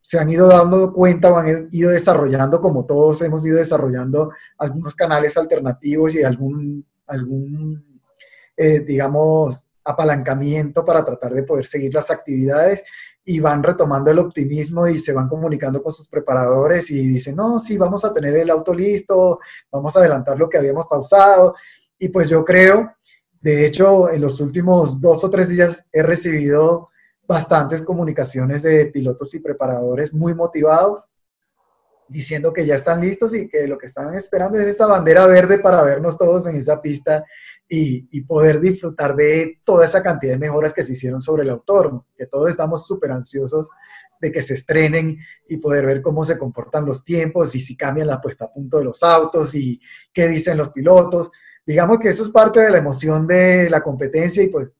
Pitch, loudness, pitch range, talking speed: 155 Hz, -16 LUFS, 145-175 Hz, 180 wpm